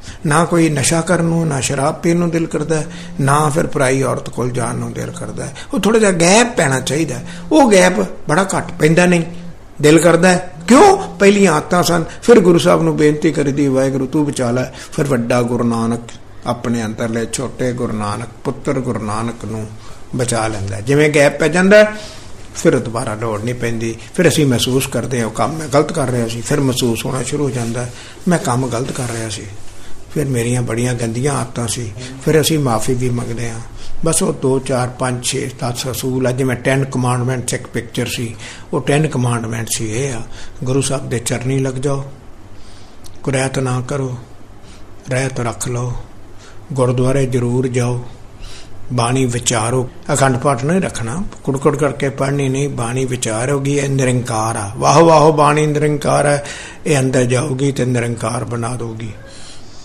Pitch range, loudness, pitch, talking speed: 115-150 Hz, -16 LUFS, 130 Hz, 170 wpm